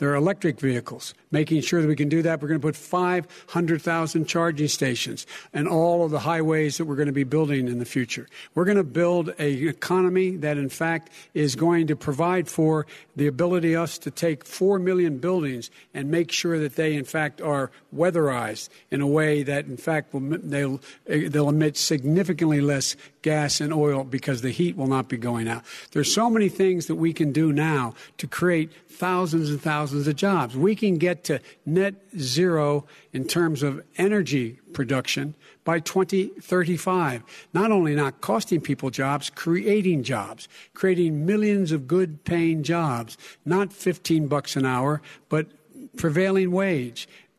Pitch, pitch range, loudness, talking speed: 155 Hz, 145-175 Hz, -24 LUFS, 175 wpm